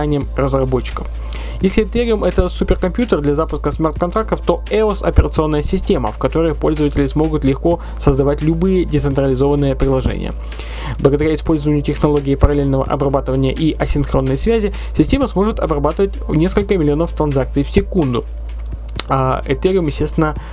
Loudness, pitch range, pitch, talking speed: -16 LUFS, 135-175 Hz, 150 Hz, 115 wpm